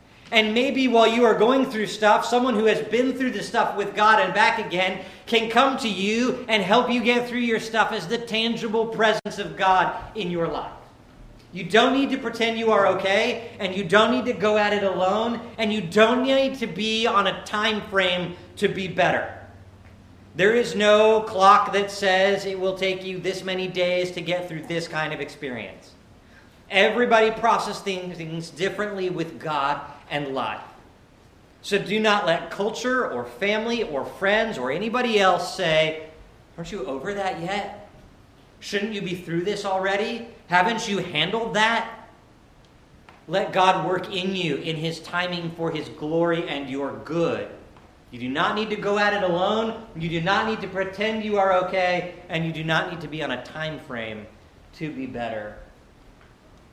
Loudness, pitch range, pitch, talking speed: -23 LUFS, 165-220 Hz, 195 Hz, 180 wpm